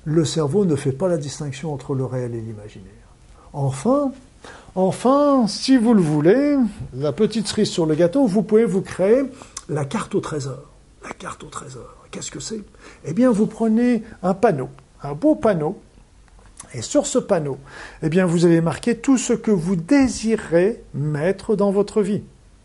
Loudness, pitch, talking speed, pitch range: -20 LUFS, 195 Hz, 175 wpm, 150-230 Hz